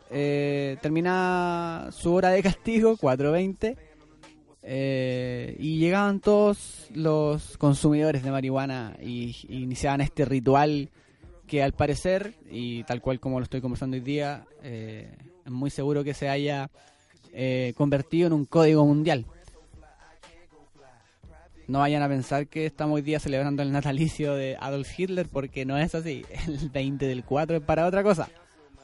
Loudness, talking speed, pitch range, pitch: -26 LUFS, 150 wpm, 135-160 Hz, 145 Hz